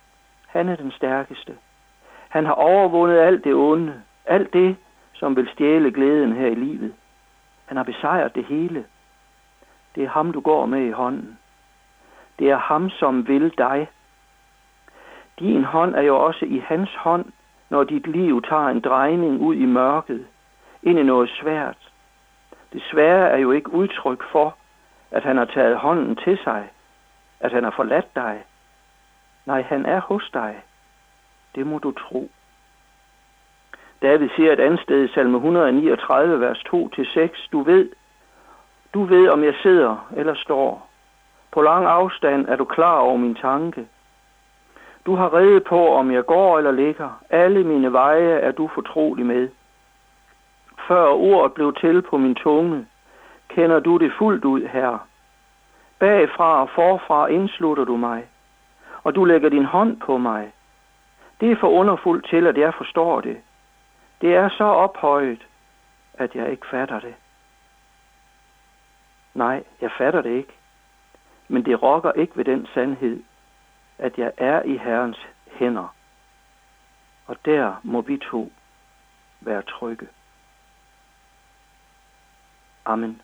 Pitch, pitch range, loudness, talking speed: 155 Hz, 130-180 Hz, -19 LUFS, 145 wpm